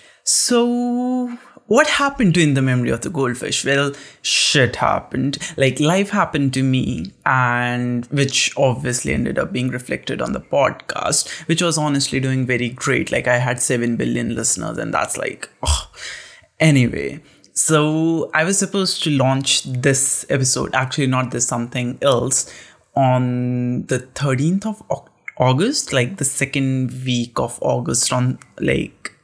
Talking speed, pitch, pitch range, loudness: 145 wpm, 135 Hz, 125-160 Hz, -18 LUFS